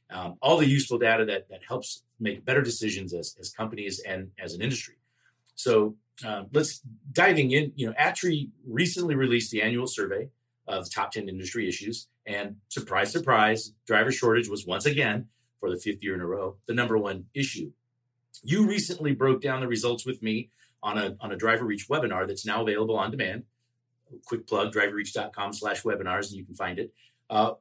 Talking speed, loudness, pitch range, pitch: 185 wpm, -27 LUFS, 105-130 Hz, 115 Hz